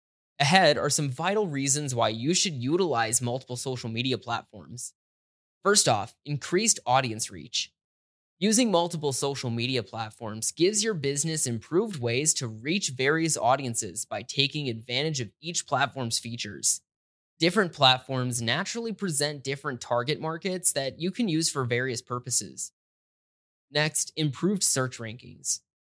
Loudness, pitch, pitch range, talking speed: -26 LUFS, 135 Hz, 120-160 Hz, 130 wpm